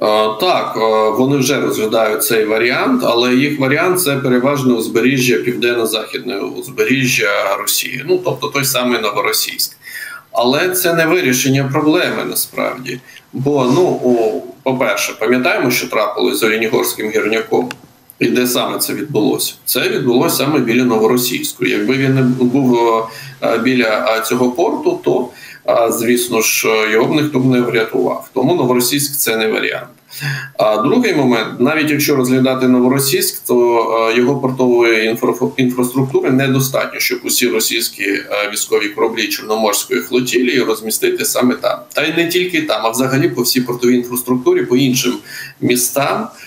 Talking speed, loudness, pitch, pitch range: 135 wpm, -14 LUFS, 125 Hz, 120-145 Hz